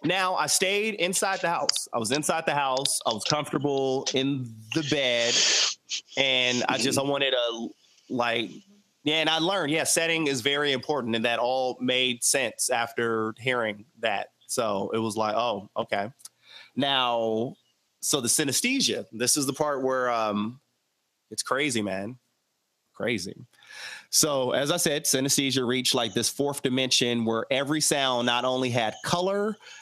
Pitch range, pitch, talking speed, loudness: 120-150 Hz, 130 Hz, 155 wpm, -25 LUFS